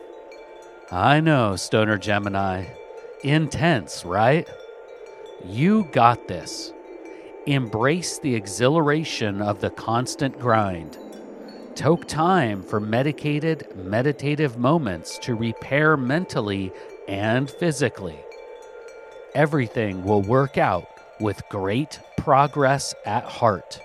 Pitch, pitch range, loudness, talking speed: 140 Hz, 110-165 Hz, -22 LUFS, 90 wpm